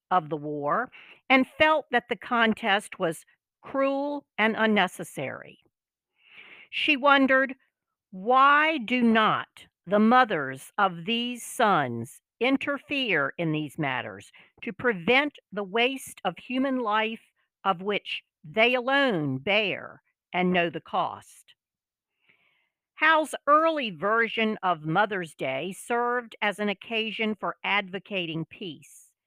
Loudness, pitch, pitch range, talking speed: -25 LUFS, 220 Hz, 180-255 Hz, 115 wpm